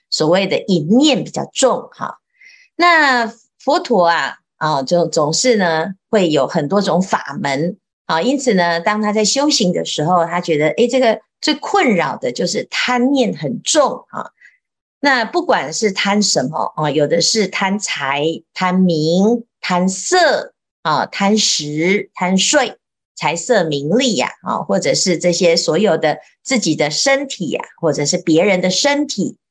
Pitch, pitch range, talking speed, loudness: 190 Hz, 170-240 Hz, 215 characters per minute, -15 LUFS